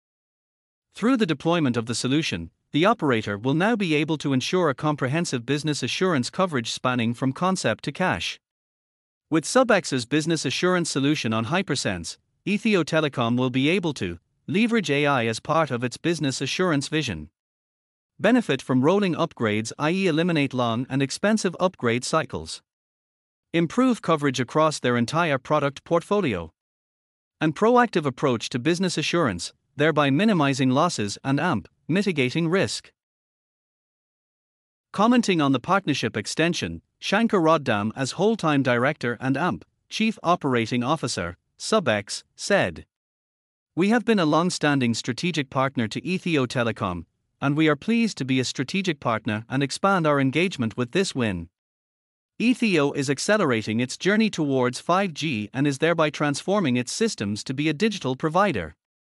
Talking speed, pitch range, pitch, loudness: 140 wpm, 125-175 Hz, 145 Hz, -23 LUFS